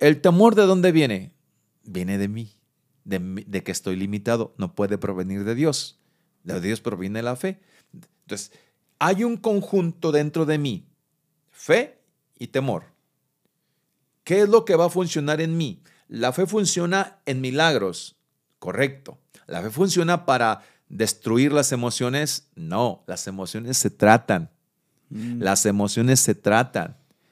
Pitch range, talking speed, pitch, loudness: 105-170 Hz, 140 wpm, 140 Hz, -22 LUFS